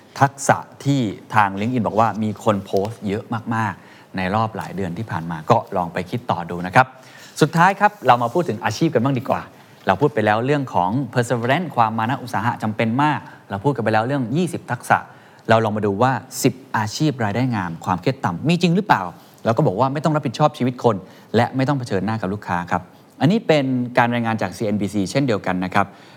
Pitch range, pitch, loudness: 105-140 Hz, 120 Hz, -20 LUFS